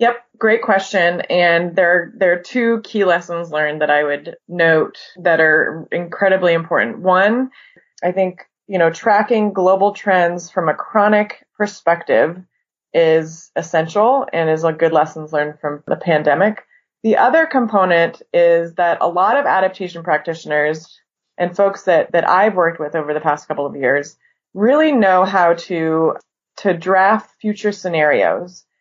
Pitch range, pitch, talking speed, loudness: 160-200 Hz, 175 Hz, 150 wpm, -16 LUFS